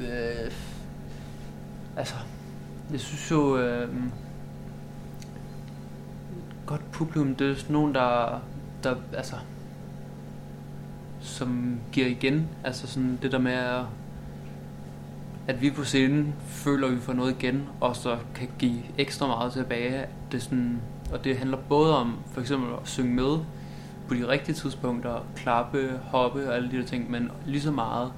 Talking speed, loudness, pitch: 145 wpm, -28 LUFS, 125 Hz